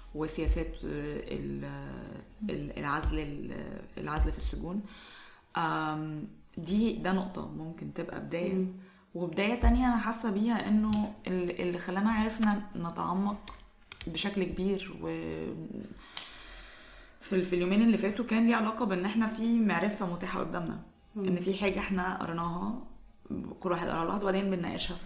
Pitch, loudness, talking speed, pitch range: 185 Hz, -32 LUFS, 115 wpm, 170-210 Hz